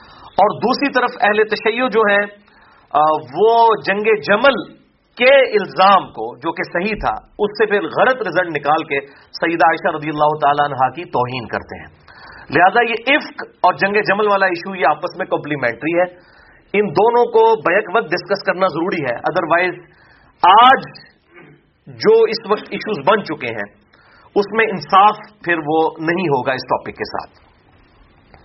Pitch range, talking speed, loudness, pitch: 155-215 Hz, 160 wpm, -16 LUFS, 185 Hz